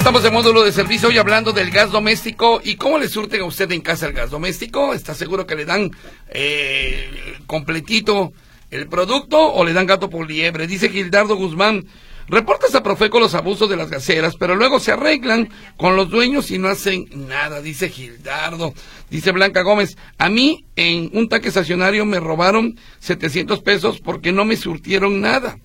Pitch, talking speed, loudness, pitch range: 195 Hz, 180 wpm, -16 LUFS, 170-220 Hz